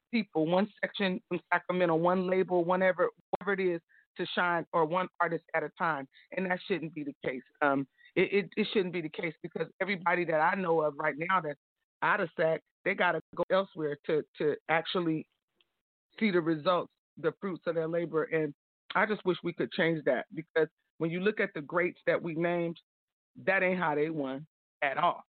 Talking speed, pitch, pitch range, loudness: 200 wpm, 175 Hz, 160-185 Hz, -31 LUFS